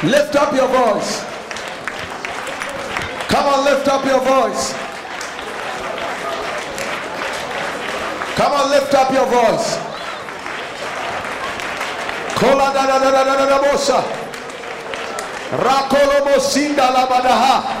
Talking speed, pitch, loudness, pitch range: 90 wpm, 275 Hz, -17 LUFS, 265-280 Hz